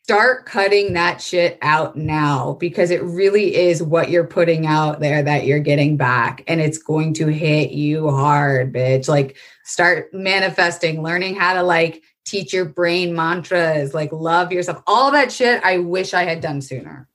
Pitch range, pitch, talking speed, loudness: 150-180 Hz, 165 Hz, 175 wpm, -17 LUFS